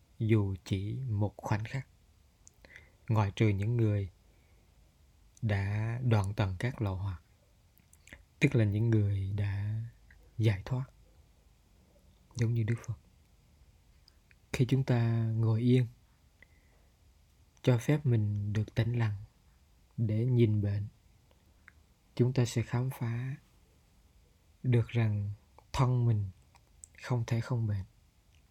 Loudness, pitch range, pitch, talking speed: -32 LUFS, 90-115 Hz, 105 Hz, 110 wpm